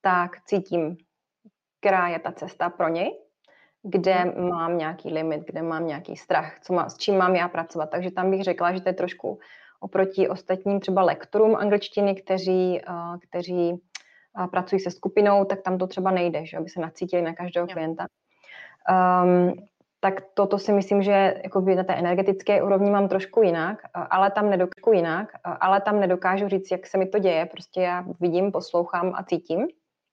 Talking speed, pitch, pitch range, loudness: 175 wpm, 185 Hz, 175-195 Hz, -24 LUFS